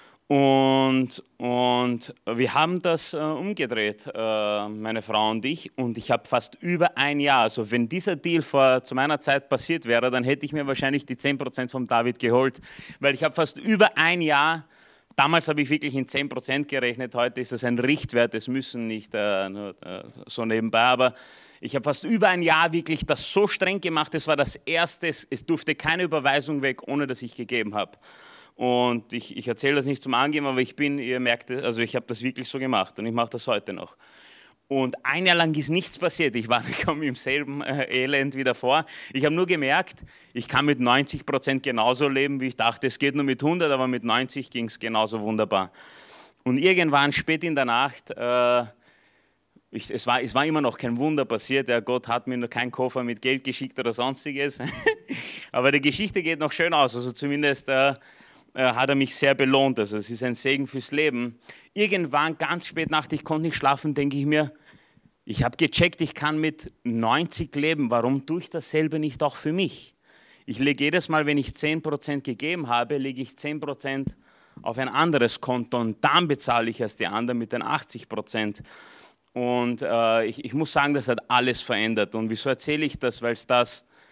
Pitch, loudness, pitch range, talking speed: 135 Hz, -24 LUFS, 120-150 Hz, 200 wpm